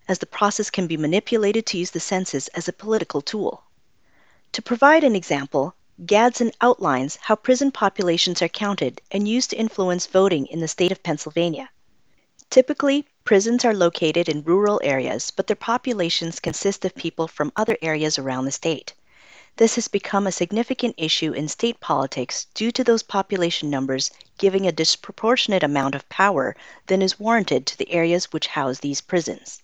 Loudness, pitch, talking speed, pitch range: -21 LUFS, 185 Hz, 170 wpm, 160-220 Hz